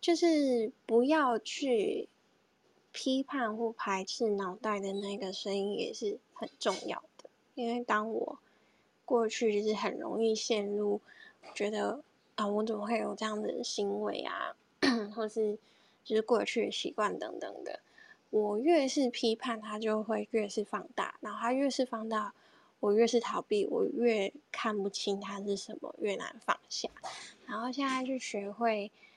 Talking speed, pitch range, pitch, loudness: 220 characters per minute, 210-245 Hz, 220 Hz, -33 LUFS